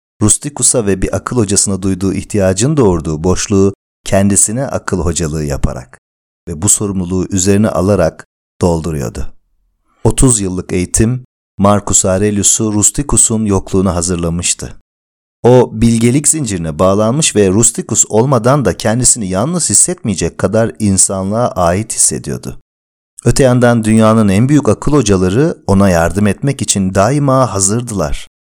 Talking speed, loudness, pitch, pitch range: 115 wpm, -11 LUFS, 100 Hz, 90-115 Hz